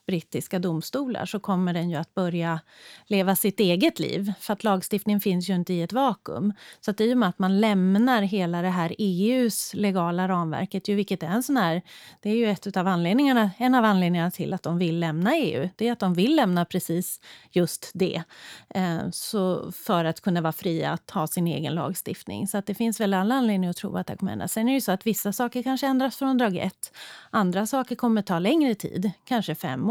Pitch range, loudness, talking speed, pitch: 175-220 Hz, -25 LUFS, 225 wpm, 195 Hz